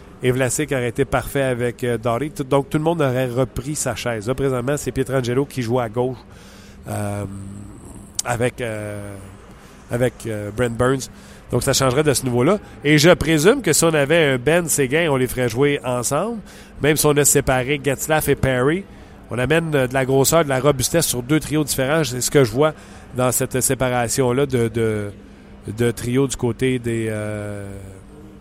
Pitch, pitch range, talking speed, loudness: 125 Hz, 110-140 Hz, 190 wpm, -19 LUFS